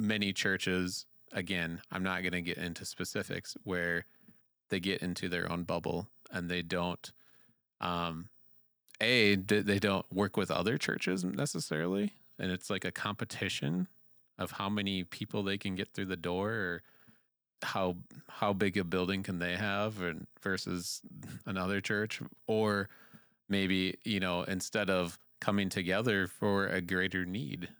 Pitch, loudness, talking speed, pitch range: 95 Hz, -34 LUFS, 150 wpm, 90-100 Hz